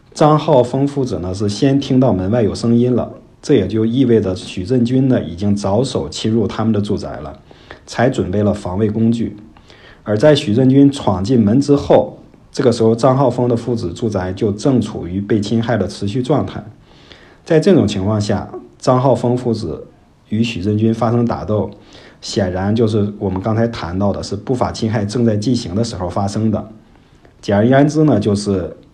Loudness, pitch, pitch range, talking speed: -16 LUFS, 110 Hz, 100-125 Hz, 275 characters per minute